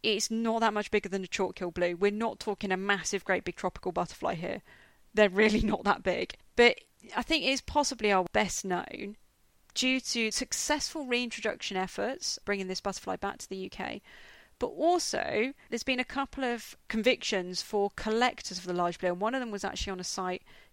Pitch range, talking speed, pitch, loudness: 190-240 Hz, 200 wpm, 210 Hz, -30 LUFS